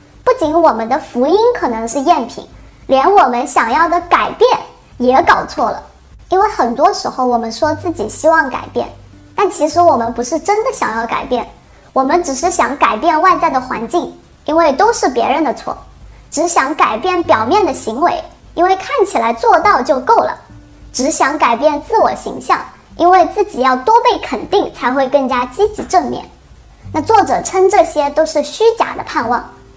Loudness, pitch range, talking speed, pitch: -13 LUFS, 280-380 Hz, 260 characters per minute, 335 Hz